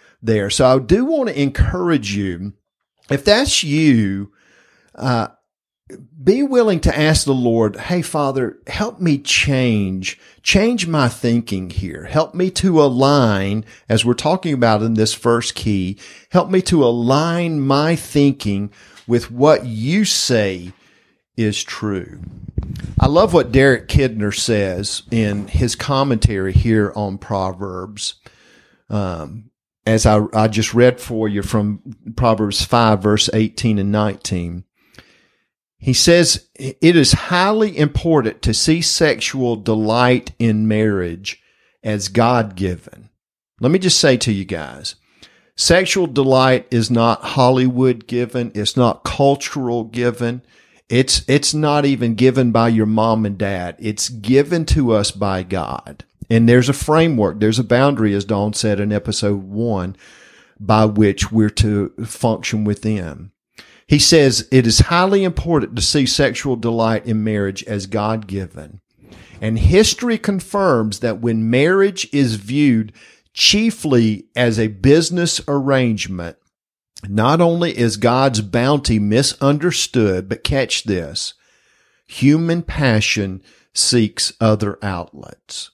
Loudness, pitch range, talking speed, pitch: -16 LUFS, 105-140 Hz, 130 wpm, 115 Hz